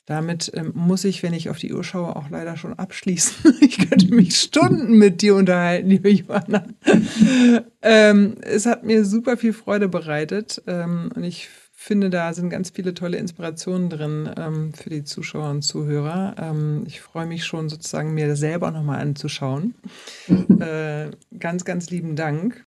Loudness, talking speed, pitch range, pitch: -19 LUFS, 165 wpm, 160-210 Hz, 185 Hz